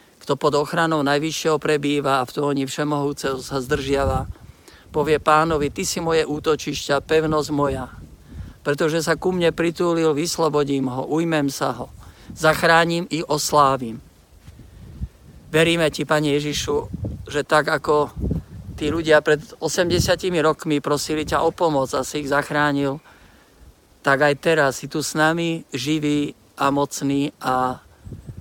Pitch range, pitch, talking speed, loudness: 135-155 Hz, 145 Hz, 135 wpm, -21 LUFS